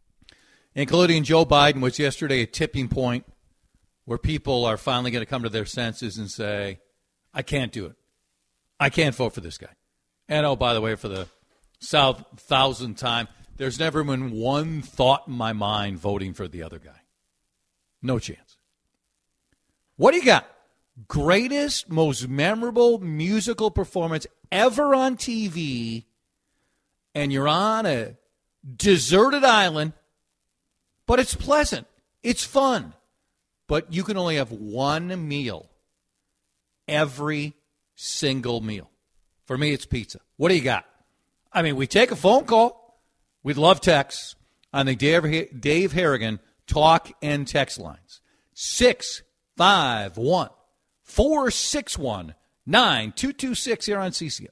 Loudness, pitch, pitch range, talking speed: -22 LUFS, 145 Hz, 120-180 Hz, 140 wpm